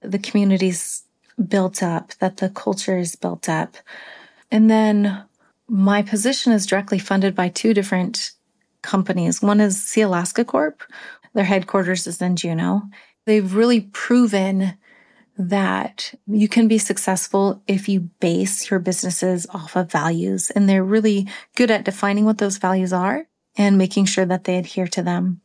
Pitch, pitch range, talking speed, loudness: 195 Hz, 185-210 Hz, 155 wpm, -19 LUFS